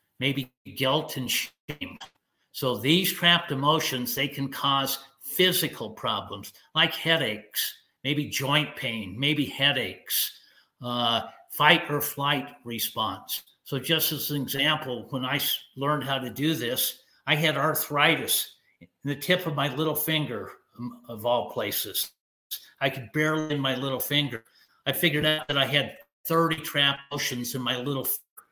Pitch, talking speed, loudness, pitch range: 140 Hz, 145 wpm, -26 LUFS, 130-155 Hz